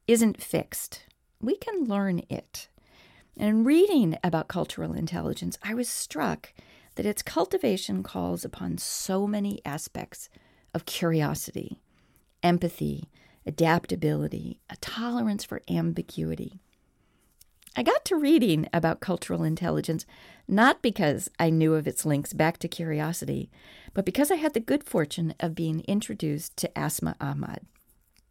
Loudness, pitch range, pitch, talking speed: -28 LUFS, 160-225 Hz, 175 Hz, 130 wpm